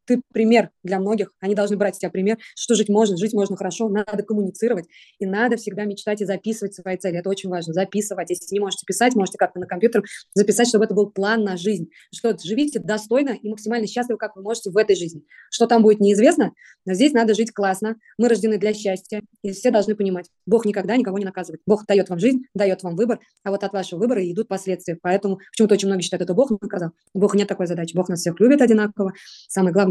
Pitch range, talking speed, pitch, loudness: 190-220 Hz, 225 wpm, 205 Hz, -21 LUFS